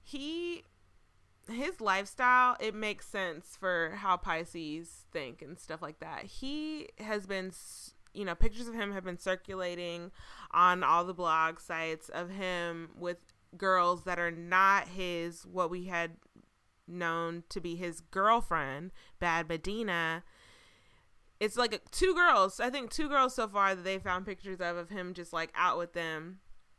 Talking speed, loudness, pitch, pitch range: 155 wpm, -32 LUFS, 180 Hz, 170-210 Hz